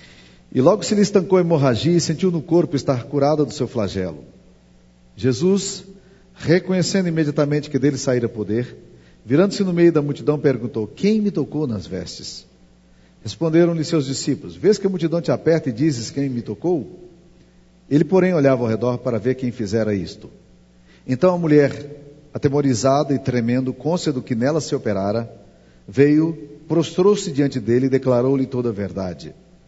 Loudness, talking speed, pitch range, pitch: -19 LUFS, 160 wpm, 115-165 Hz, 140 Hz